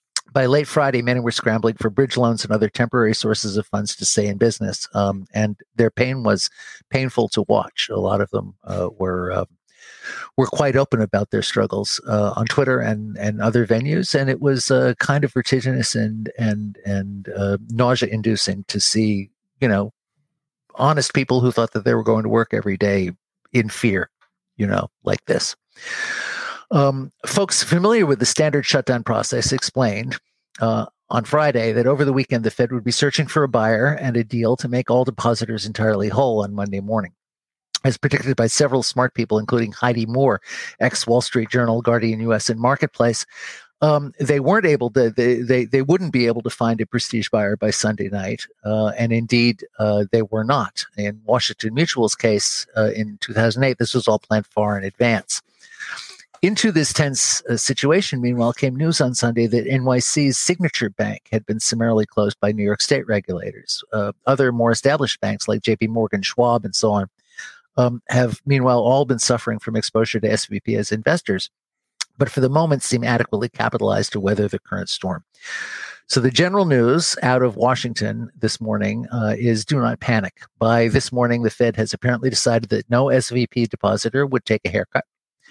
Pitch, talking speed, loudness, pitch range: 120 Hz, 185 wpm, -20 LUFS, 110-130 Hz